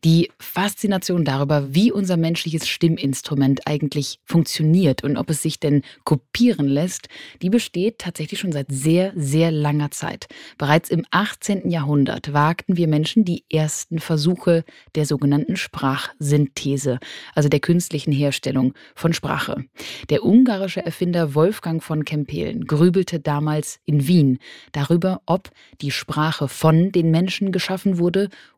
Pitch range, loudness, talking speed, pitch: 145-180 Hz, -20 LUFS, 130 wpm, 160 Hz